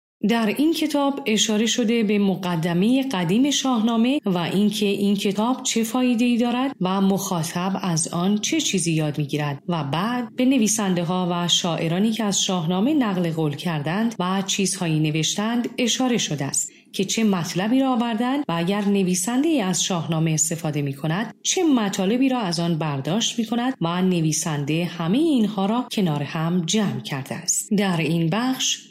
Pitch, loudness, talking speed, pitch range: 195 Hz, -22 LUFS, 160 wpm, 170-235 Hz